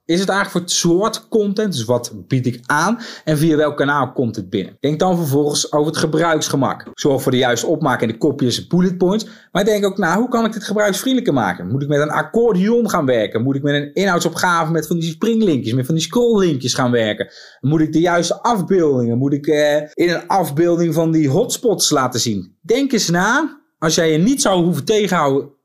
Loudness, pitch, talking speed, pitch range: -17 LUFS, 165 Hz, 220 wpm, 145-200 Hz